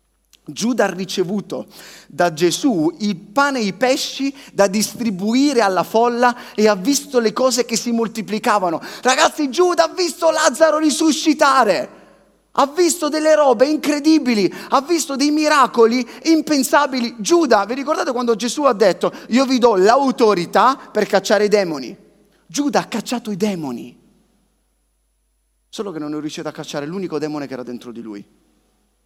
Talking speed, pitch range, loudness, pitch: 150 wpm, 200-285 Hz, -17 LUFS, 245 Hz